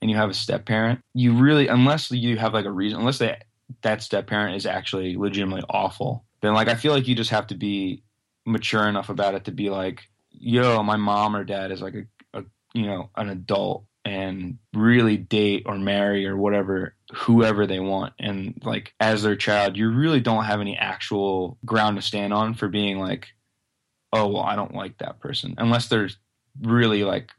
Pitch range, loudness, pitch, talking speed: 100-115 Hz, -23 LUFS, 105 Hz, 200 wpm